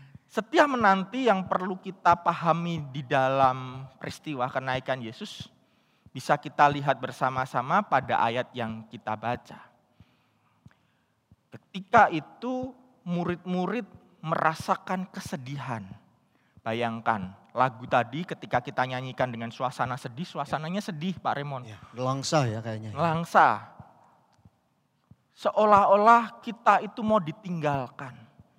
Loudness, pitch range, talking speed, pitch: -27 LUFS, 130-190 Hz, 100 wpm, 150 Hz